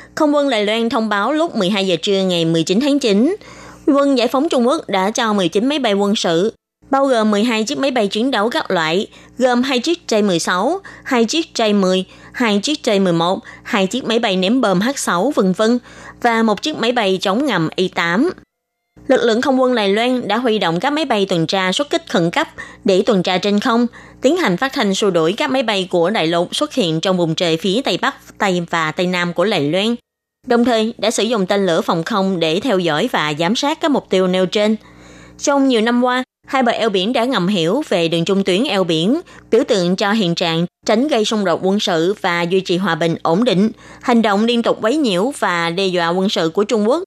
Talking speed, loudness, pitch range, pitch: 230 wpm, -16 LUFS, 185-245 Hz, 210 Hz